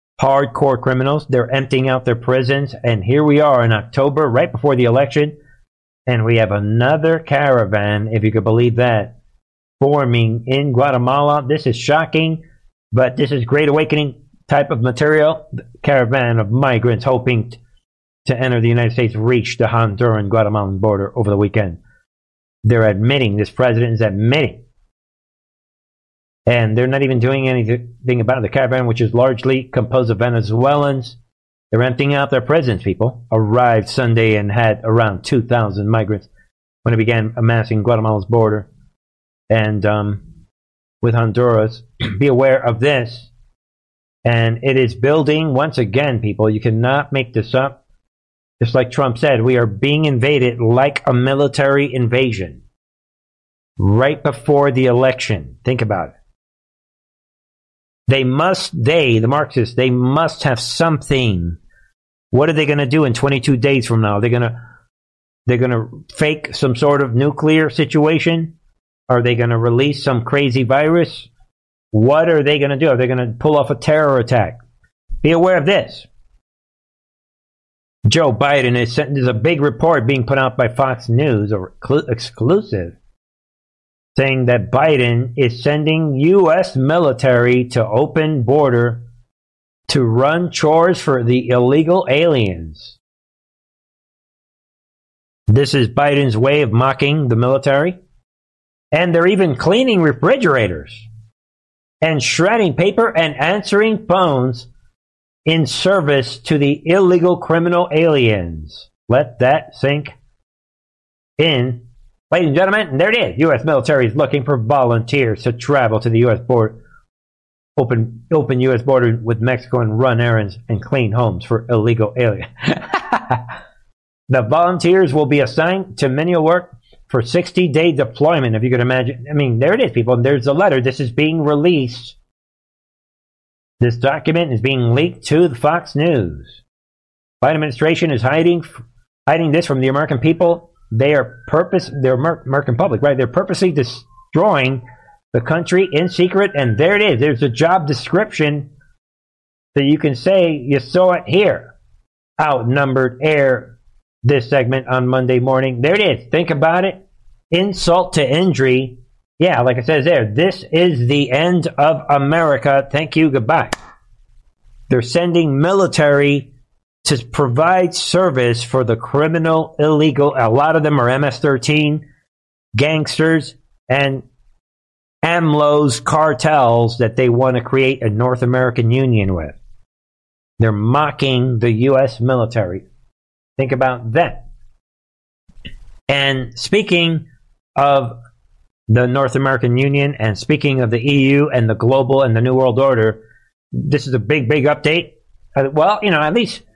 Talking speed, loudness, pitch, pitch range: 145 wpm, -15 LUFS, 130 Hz, 115-150 Hz